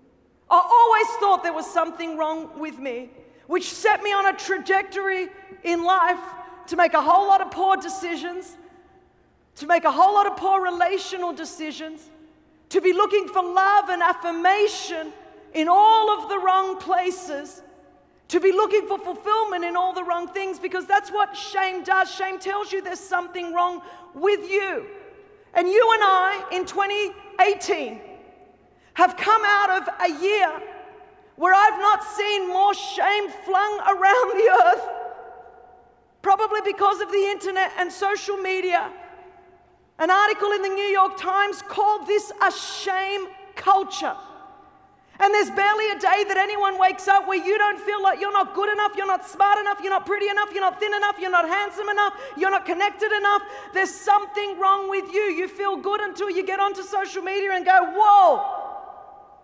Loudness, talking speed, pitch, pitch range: -21 LUFS, 170 wpm, 385 Hz, 365-400 Hz